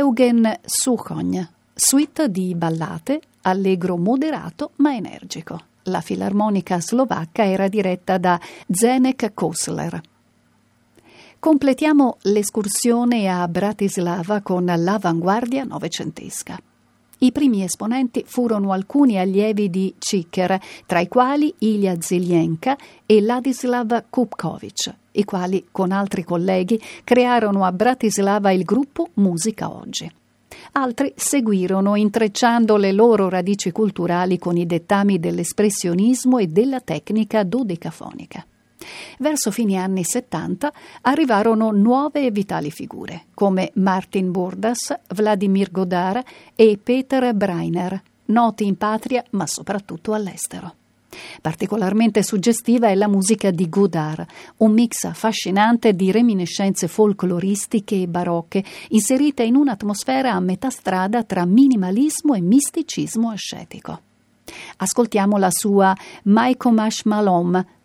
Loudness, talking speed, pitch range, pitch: -19 LUFS, 105 wpm, 185-245 Hz, 210 Hz